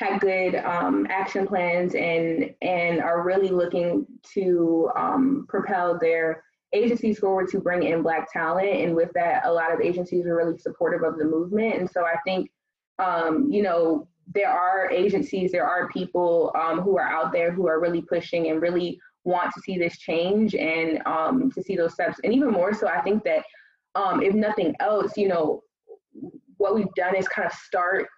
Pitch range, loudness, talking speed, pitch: 165-200 Hz, -24 LUFS, 190 wpm, 180 Hz